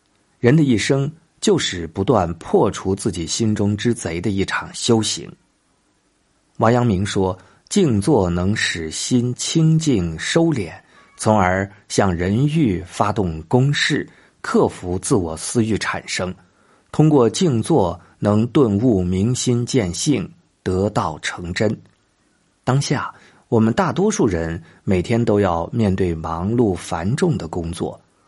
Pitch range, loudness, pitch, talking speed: 90-125 Hz, -19 LUFS, 105 Hz, 185 characters per minute